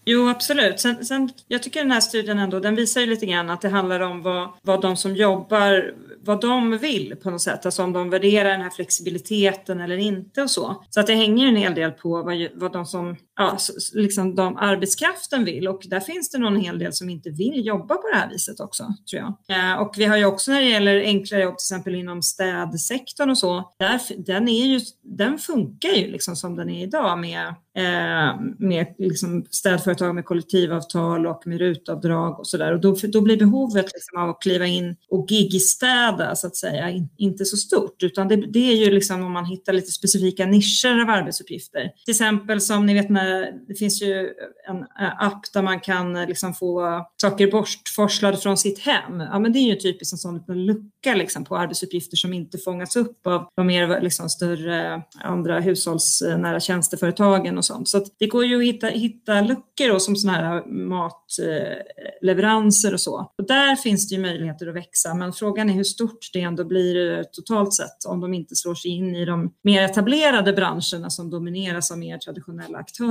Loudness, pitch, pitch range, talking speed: -21 LUFS, 190 Hz, 180-210 Hz, 205 wpm